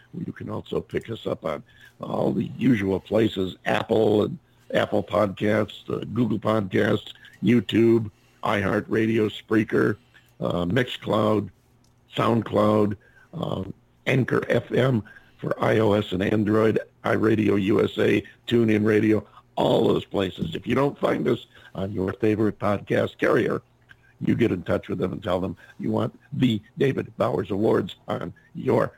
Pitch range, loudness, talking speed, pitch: 105-110 Hz, -24 LUFS, 135 wpm, 105 Hz